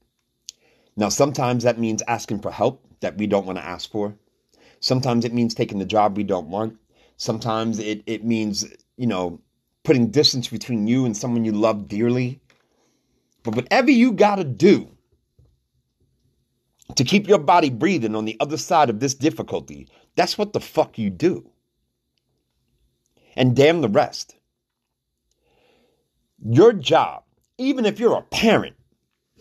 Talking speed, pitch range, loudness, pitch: 150 wpm, 110-140 Hz, -20 LUFS, 120 Hz